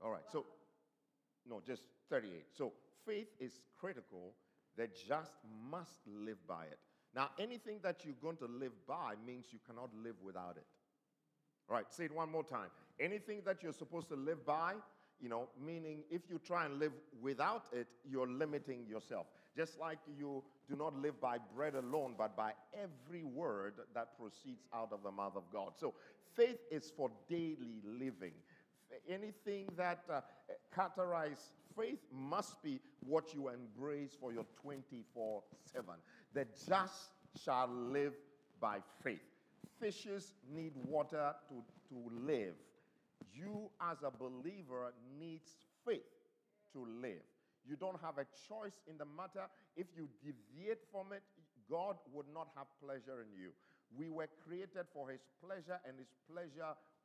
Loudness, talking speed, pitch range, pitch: -46 LUFS, 155 wpm, 130-180 Hz, 150 Hz